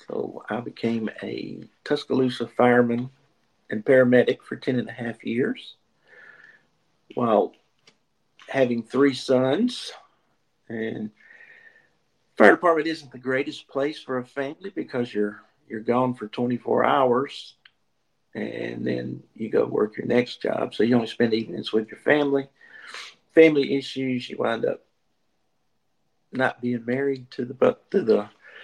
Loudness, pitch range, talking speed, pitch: -24 LUFS, 120-140 Hz, 135 wpm, 130 Hz